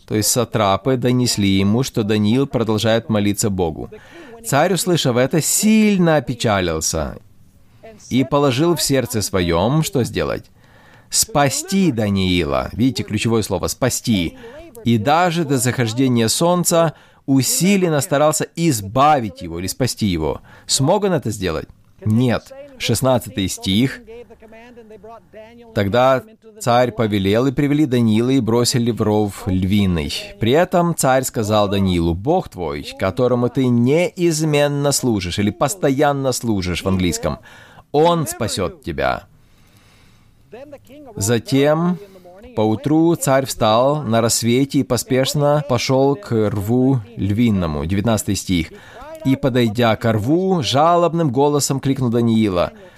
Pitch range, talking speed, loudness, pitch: 110-150 Hz, 110 wpm, -17 LUFS, 125 Hz